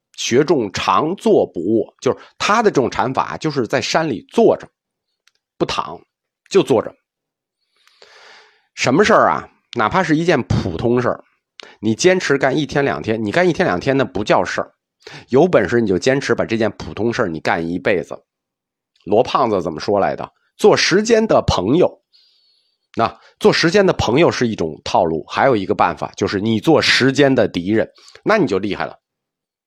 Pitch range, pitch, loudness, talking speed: 110-185 Hz, 135 Hz, -17 LUFS, 255 characters per minute